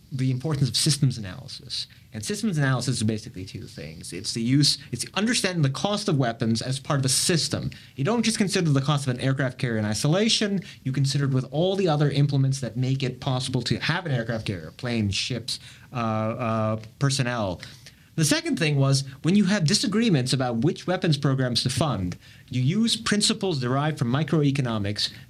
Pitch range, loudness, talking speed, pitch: 120-155 Hz, -24 LUFS, 190 wpm, 135 Hz